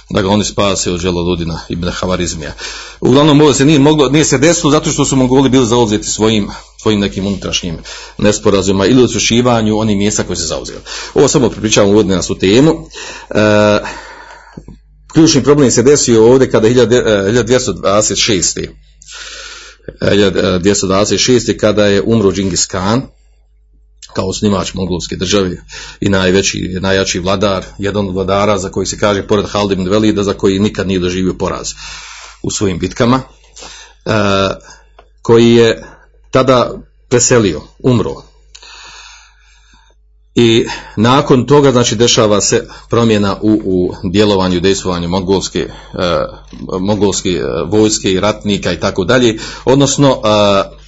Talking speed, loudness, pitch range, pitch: 125 wpm, -12 LUFS, 95-120 Hz, 105 Hz